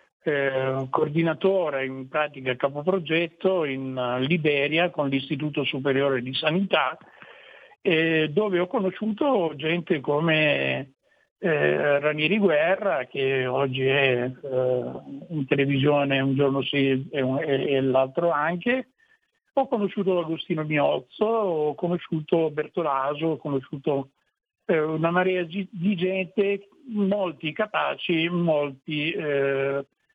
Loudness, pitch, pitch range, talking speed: -24 LUFS, 155 Hz, 135-180 Hz, 110 wpm